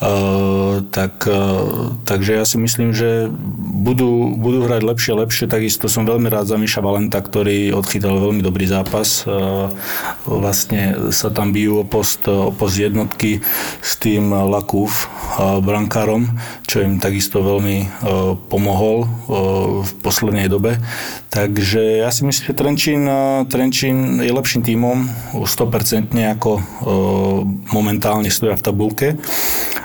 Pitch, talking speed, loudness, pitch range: 105 Hz, 135 wpm, -16 LUFS, 100-115 Hz